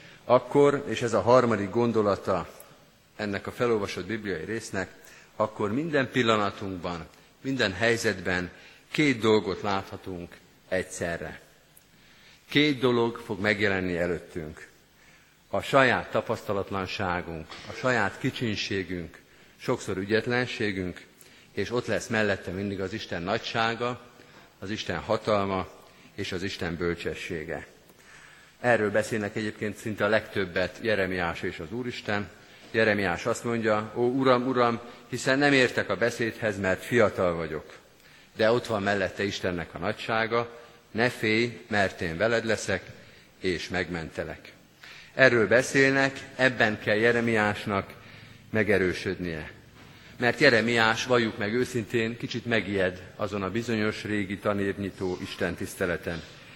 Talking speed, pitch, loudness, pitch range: 115 wpm, 105 Hz, -27 LUFS, 95-120 Hz